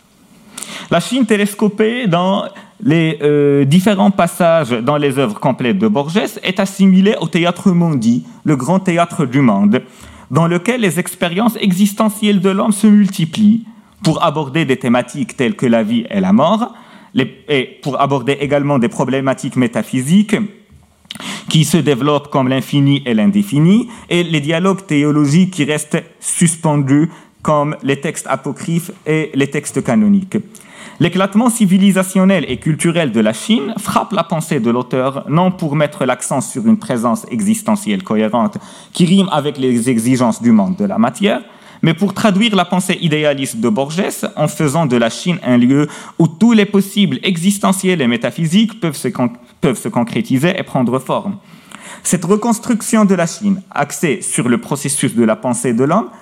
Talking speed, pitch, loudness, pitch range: 160 wpm, 180 Hz, -14 LUFS, 145-205 Hz